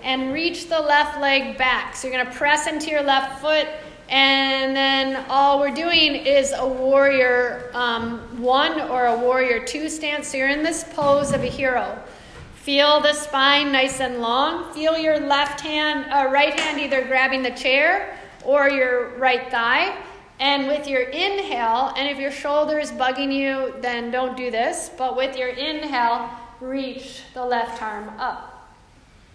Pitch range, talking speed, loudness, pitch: 255-295 Hz, 170 wpm, -20 LUFS, 270 Hz